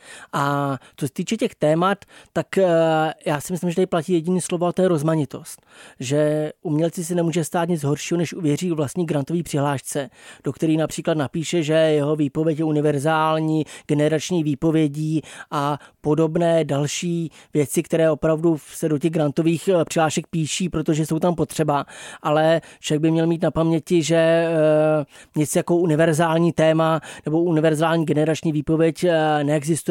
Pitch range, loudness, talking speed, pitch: 150-170 Hz, -21 LUFS, 155 wpm, 160 Hz